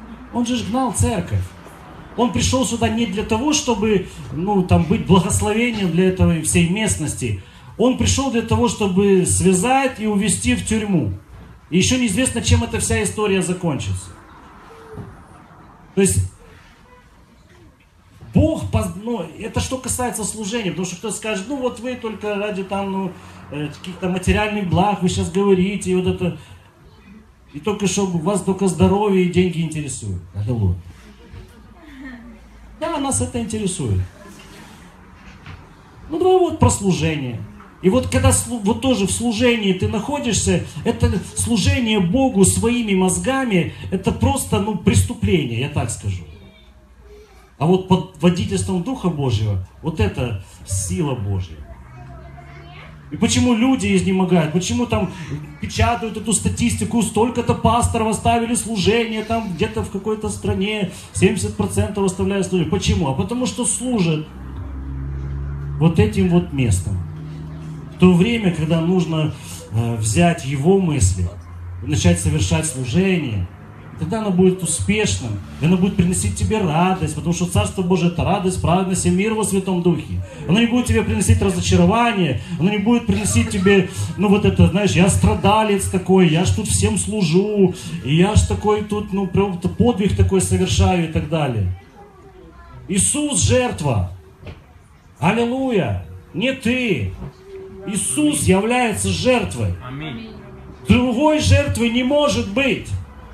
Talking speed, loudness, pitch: 135 wpm, -19 LUFS, 180 Hz